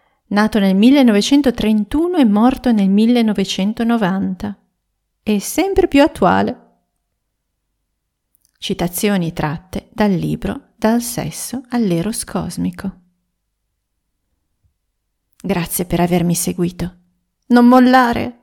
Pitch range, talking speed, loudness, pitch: 175-240 Hz, 80 wpm, -15 LUFS, 205 Hz